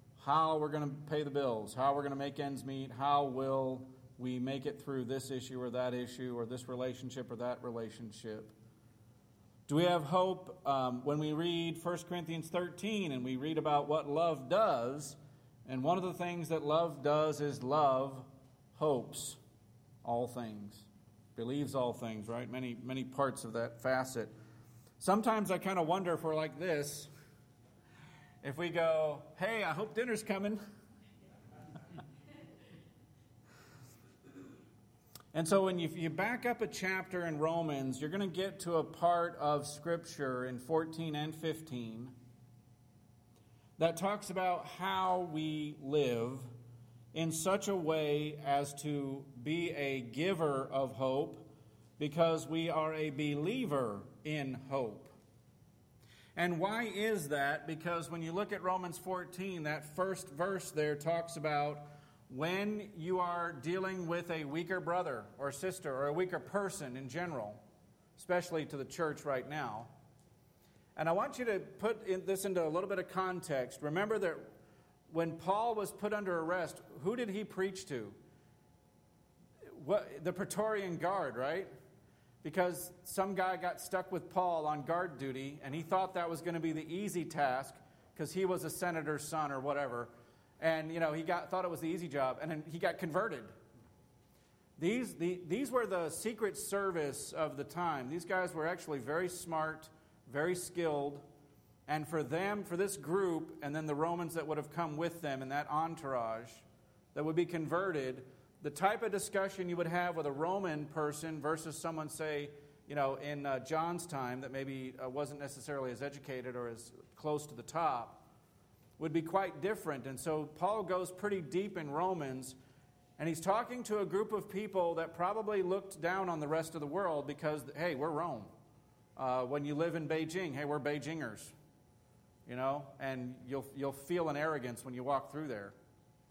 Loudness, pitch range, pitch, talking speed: -37 LUFS, 135-175 Hz, 155 Hz, 170 wpm